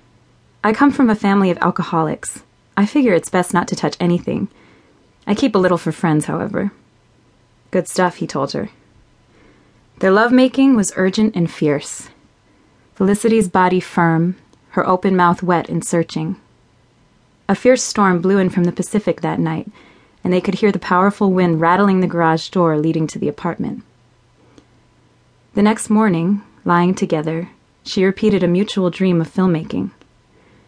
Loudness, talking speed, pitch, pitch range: -17 LUFS, 155 wpm, 185 Hz, 170-200 Hz